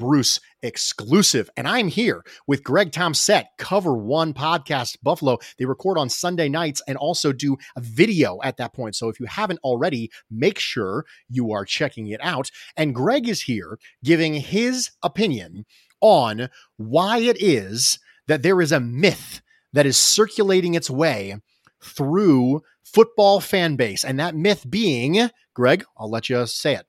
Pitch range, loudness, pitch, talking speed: 125-180 Hz, -20 LUFS, 145 Hz, 165 wpm